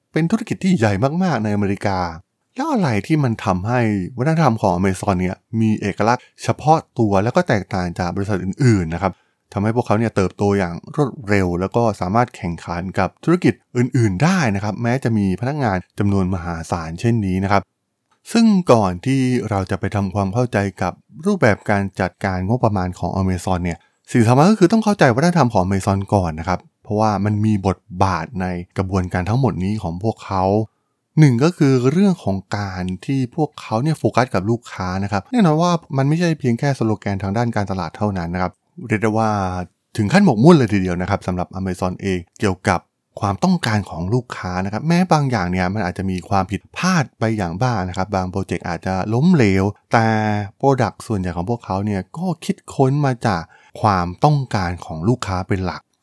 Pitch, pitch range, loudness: 105 Hz, 95-125 Hz, -19 LUFS